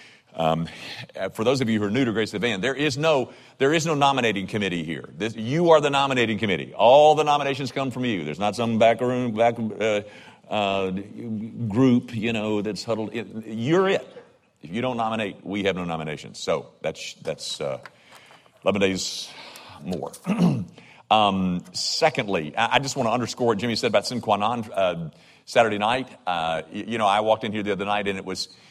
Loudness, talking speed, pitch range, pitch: -23 LUFS, 195 wpm, 95-125 Hz, 110 Hz